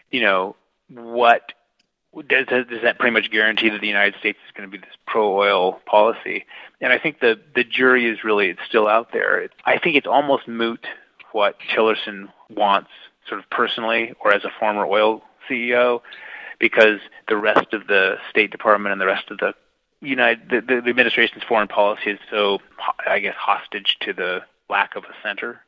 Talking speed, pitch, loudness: 180 wpm, 120 Hz, -19 LUFS